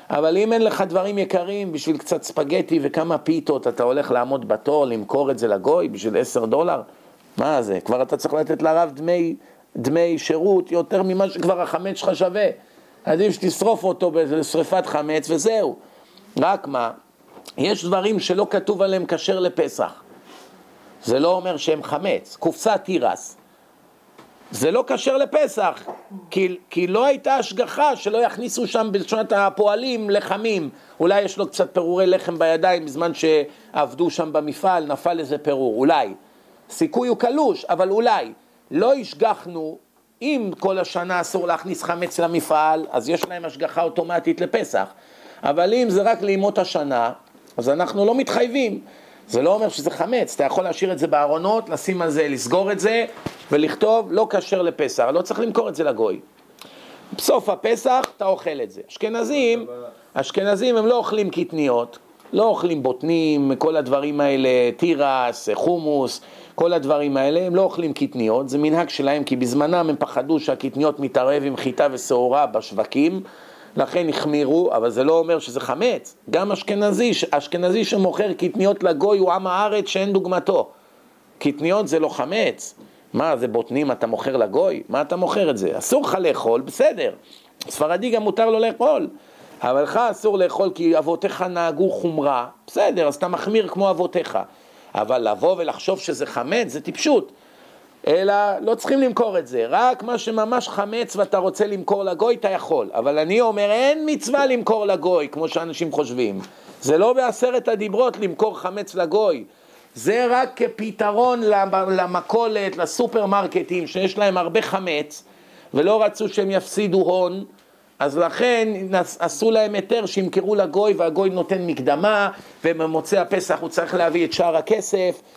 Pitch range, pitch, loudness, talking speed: 160-210 Hz, 185 Hz, -20 LUFS, 150 wpm